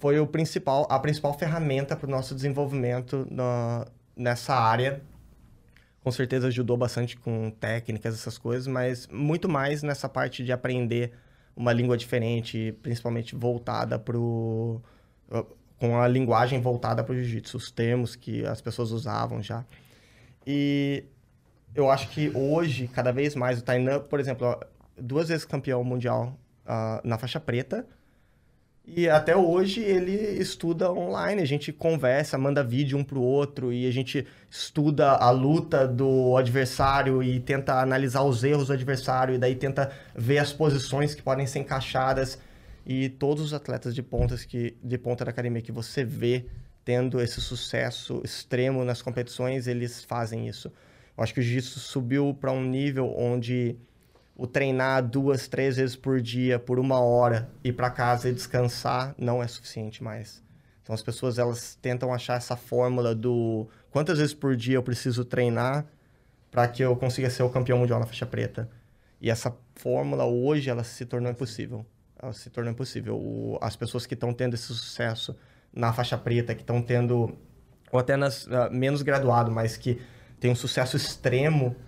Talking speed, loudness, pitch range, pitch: 165 wpm, -27 LUFS, 120-135 Hz, 125 Hz